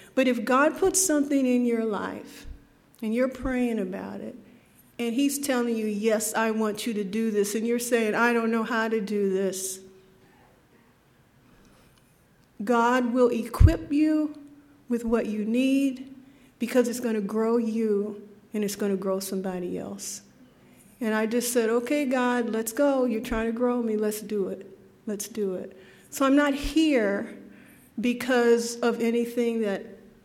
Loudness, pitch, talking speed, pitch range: -26 LUFS, 230 Hz, 165 wpm, 210-250 Hz